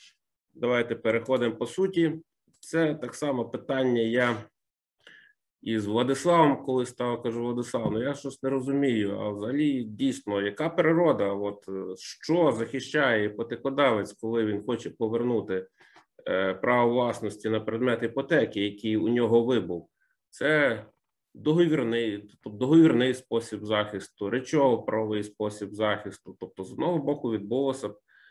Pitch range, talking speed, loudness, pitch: 105-135 Hz, 125 wpm, -27 LUFS, 115 Hz